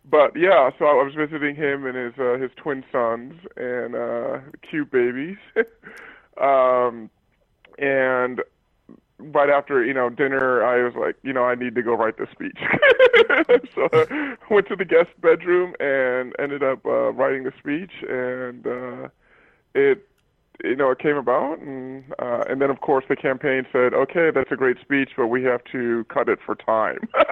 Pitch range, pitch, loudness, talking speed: 125-180 Hz, 135 Hz, -21 LUFS, 175 wpm